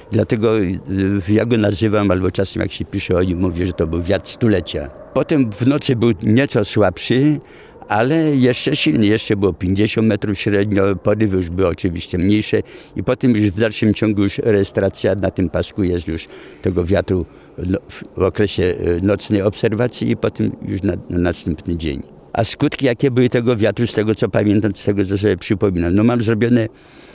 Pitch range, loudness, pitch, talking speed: 95-115 Hz, -17 LUFS, 105 Hz, 175 wpm